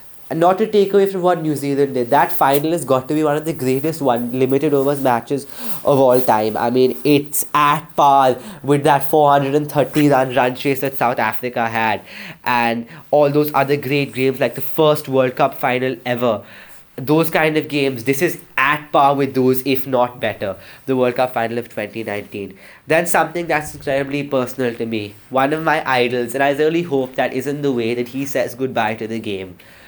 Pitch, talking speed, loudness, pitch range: 135 Hz, 200 wpm, -17 LUFS, 125-150 Hz